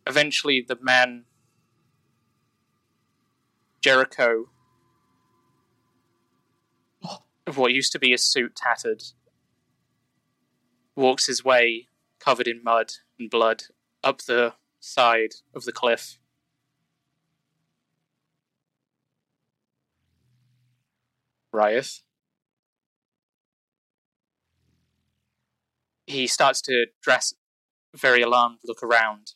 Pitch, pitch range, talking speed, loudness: 125 Hz, 120-140 Hz, 75 wpm, -22 LUFS